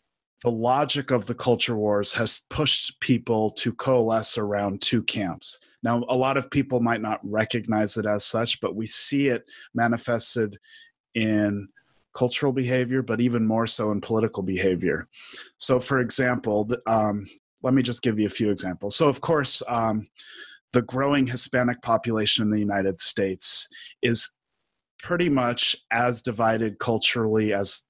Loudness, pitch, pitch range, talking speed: -23 LUFS, 115 Hz, 105-125 Hz, 155 wpm